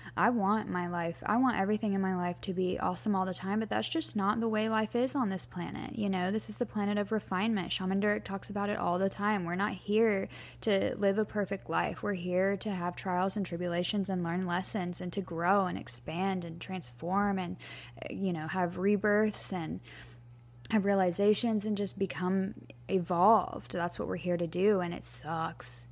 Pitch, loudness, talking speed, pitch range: 195 Hz, -32 LUFS, 205 wpm, 180-210 Hz